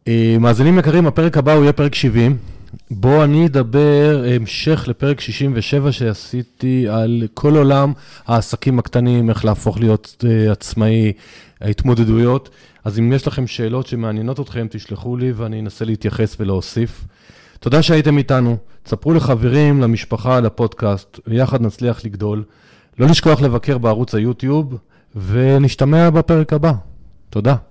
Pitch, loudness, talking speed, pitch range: 120 Hz, -15 LUFS, 125 wpm, 110-140 Hz